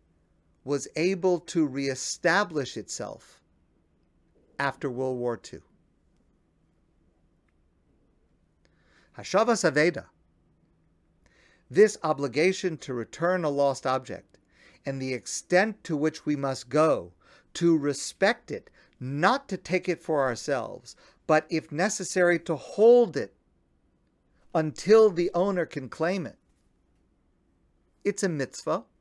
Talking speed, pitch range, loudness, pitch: 105 wpm, 135-180 Hz, -26 LUFS, 155 Hz